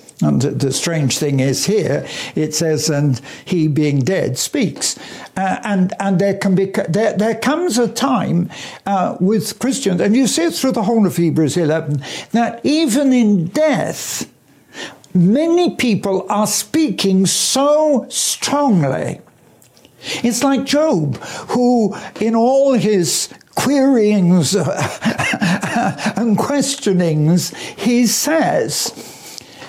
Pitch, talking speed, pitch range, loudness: 210 Hz, 120 wpm, 175-255 Hz, -16 LUFS